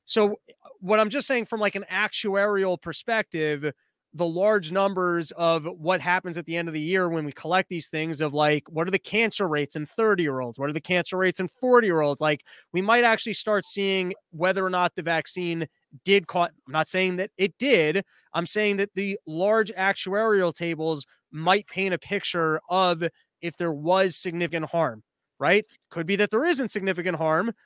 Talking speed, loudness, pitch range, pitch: 195 wpm, -25 LUFS, 165-200 Hz, 180 Hz